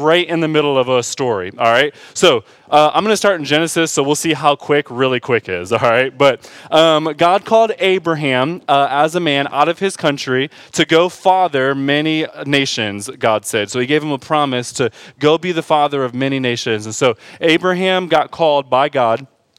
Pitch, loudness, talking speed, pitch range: 150 Hz, -15 LUFS, 210 wpm, 135-165 Hz